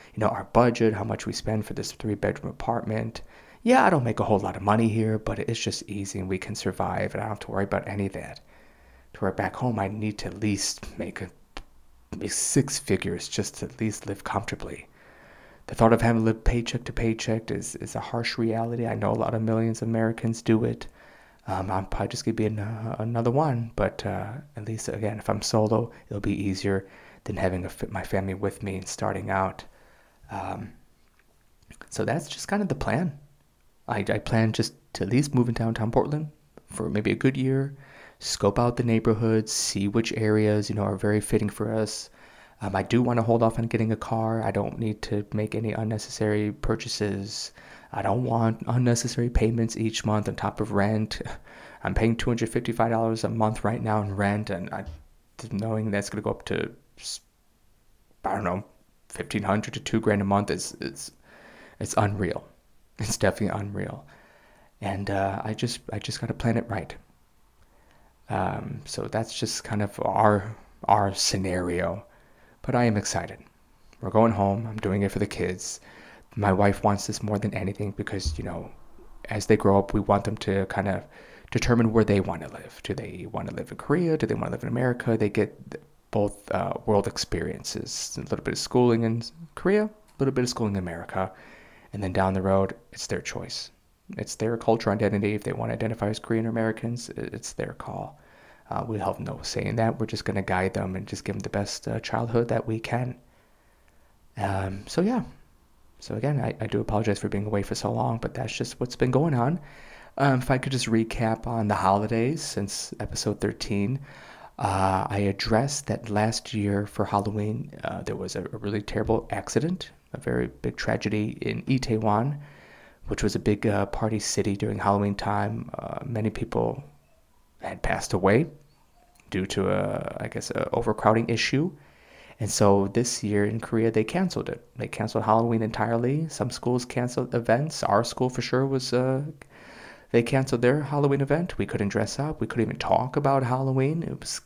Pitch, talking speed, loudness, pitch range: 110 Hz, 200 wpm, -27 LUFS, 100-115 Hz